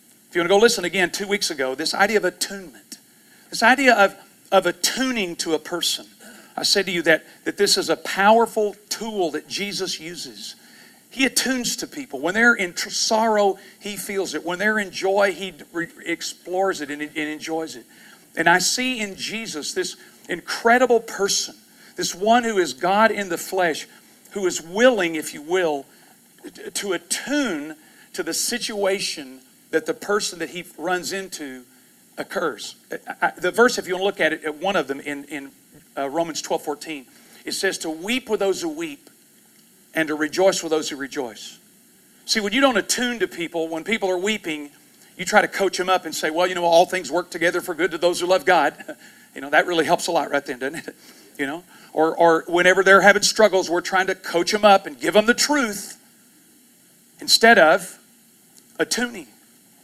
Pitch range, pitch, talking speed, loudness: 170-225 Hz, 190 Hz, 195 wpm, -21 LUFS